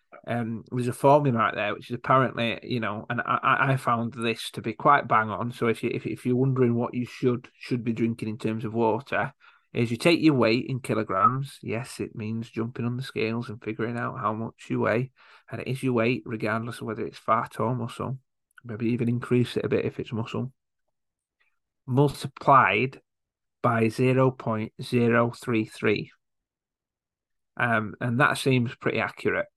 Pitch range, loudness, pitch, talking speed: 110-125 Hz, -26 LUFS, 120 Hz, 190 wpm